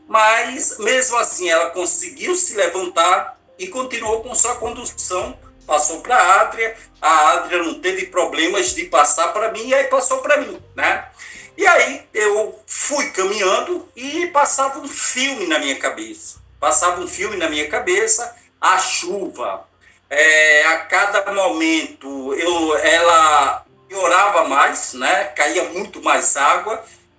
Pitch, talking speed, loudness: 250 Hz, 140 wpm, -15 LUFS